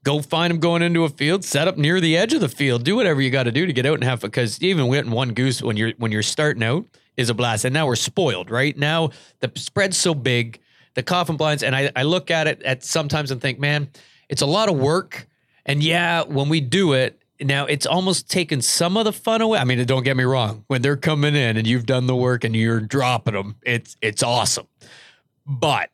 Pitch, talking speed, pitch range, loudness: 140 Hz, 245 wpm, 125-160 Hz, -20 LUFS